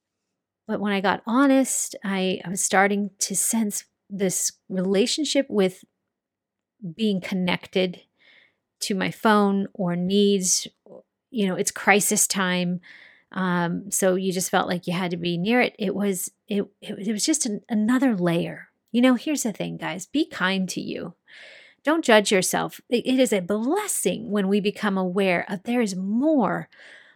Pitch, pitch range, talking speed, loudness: 200 Hz, 185-230 Hz, 170 wpm, -23 LUFS